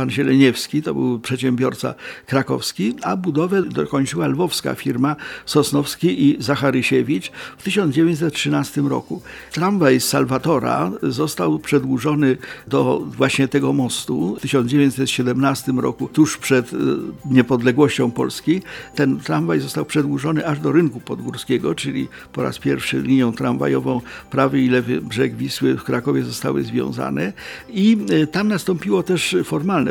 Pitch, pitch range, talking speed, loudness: 140 Hz, 130-155 Hz, 120 wpm, -19 LUFS